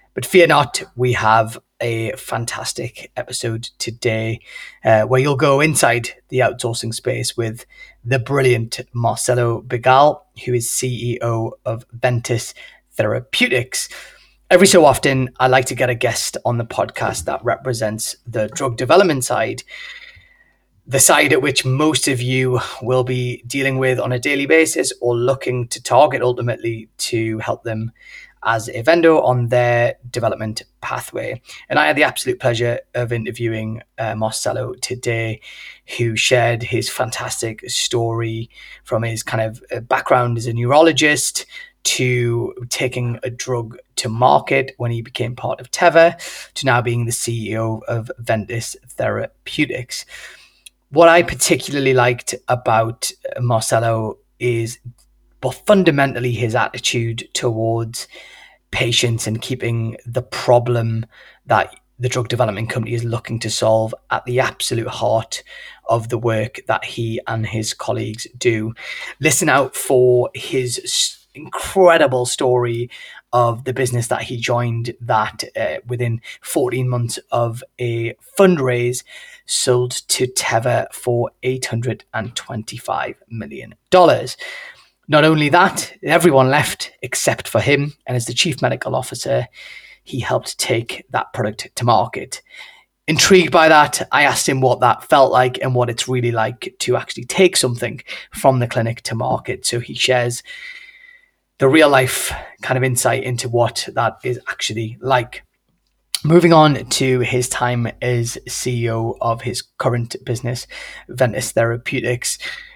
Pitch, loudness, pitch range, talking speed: 125 Hz, -17 LUFS, 115-130 Hz, 140 wpm